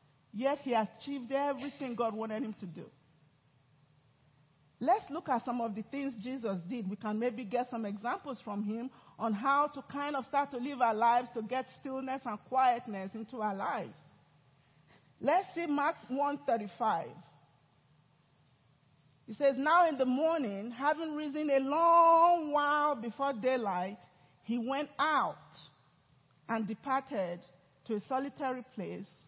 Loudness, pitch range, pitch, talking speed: -33 LUFS, 195-275 Hz, 240 Hz, 145 wpm